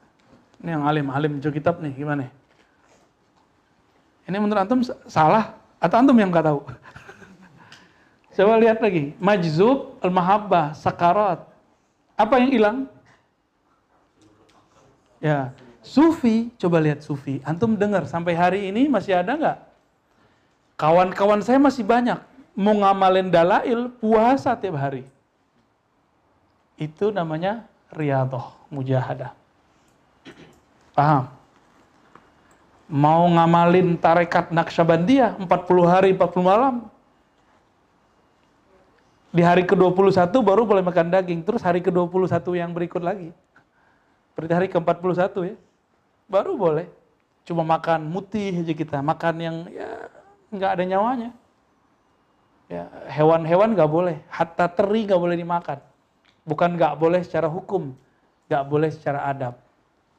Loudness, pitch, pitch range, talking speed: -20 LUFS, 175 Hz, 155-205 Hz, 110 wpm